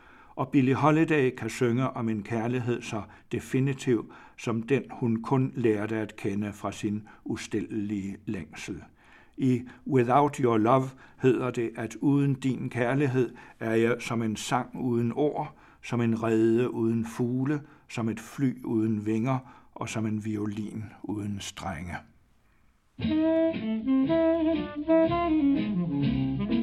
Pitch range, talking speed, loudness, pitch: 110-140 Hz, 120 wpm, -28 LUFS, 120 Hz